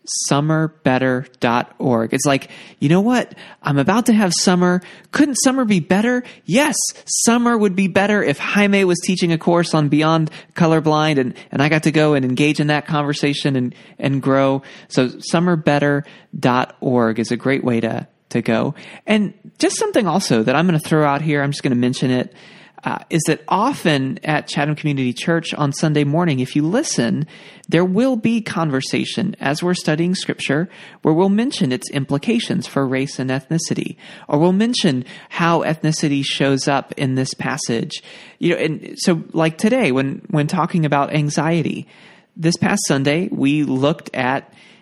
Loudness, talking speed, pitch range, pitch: -18 LUFS, 170 wpm, 140-195 Hz, 155 Hz